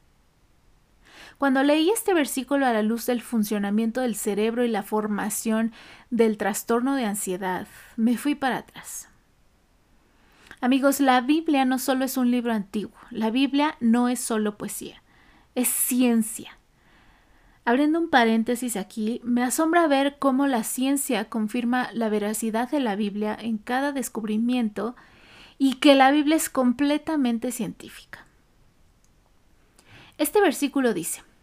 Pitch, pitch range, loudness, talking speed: 245 Hz, 220-275 Hz, -24 LUFS, 130 wpm